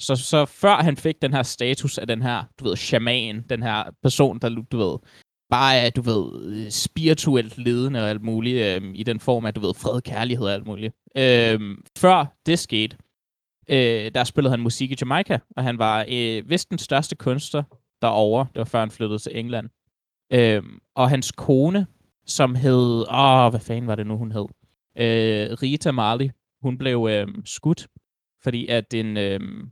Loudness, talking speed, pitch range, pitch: -22 LUFS, 185 wpm, 110-135 Hz, 120 Hz